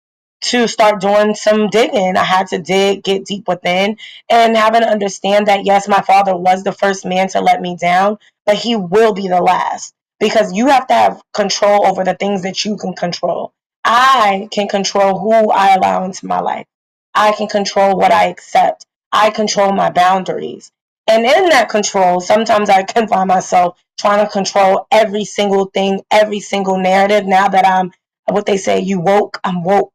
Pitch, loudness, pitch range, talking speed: 200 Hz, -13 LUFS, 190-210 Hz, 190 wpm